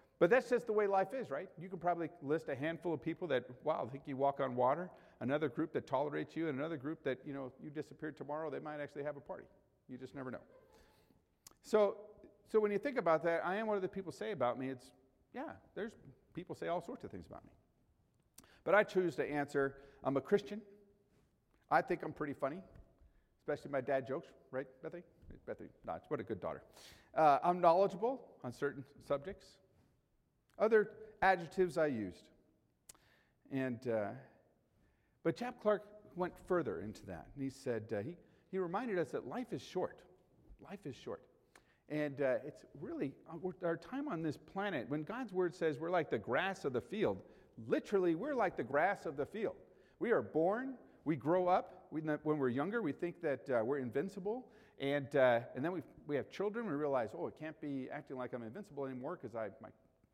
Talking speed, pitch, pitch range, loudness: 200 wpm, 160 Hz, 140-195 Hz, -38 LUFS